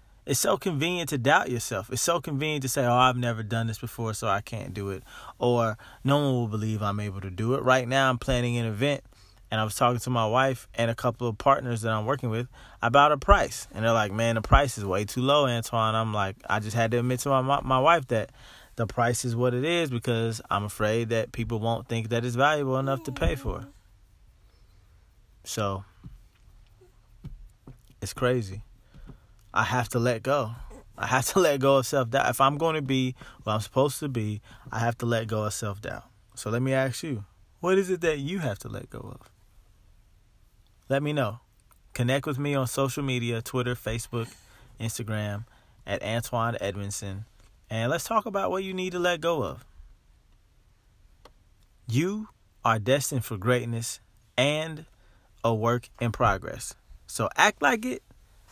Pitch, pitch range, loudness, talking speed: 115 Hz, 105-135 Hz, -27 LUFS, 195 wpm